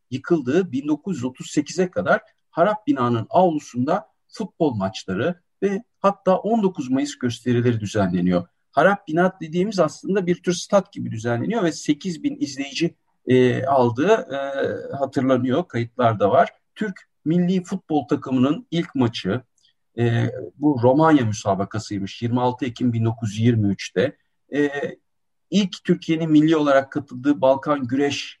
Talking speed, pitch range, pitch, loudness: 115 wpm, 125-180 Hz, 150 Hz, -22 LUFS